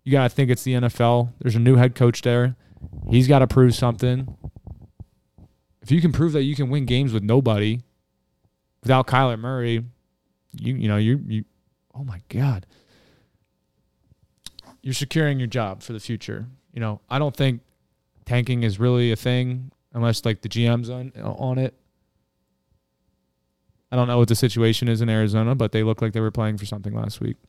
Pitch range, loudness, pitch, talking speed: 110-130 Hz, -21 LUFS, 120 Hz, 185 wpm